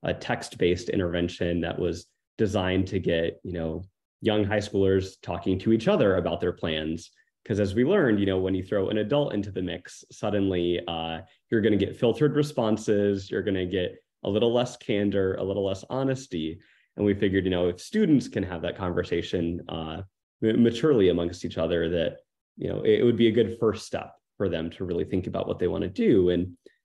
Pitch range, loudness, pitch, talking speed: 85-110 Hz, -26 LUFS, 95 Hz, 205 wpm